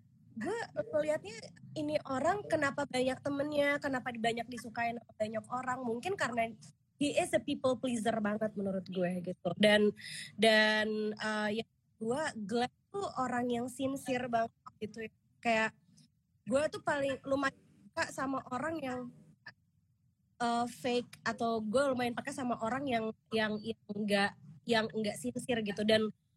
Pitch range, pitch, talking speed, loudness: 215-270 Hz, 235 Hz, 135 wpm, -34 LUFS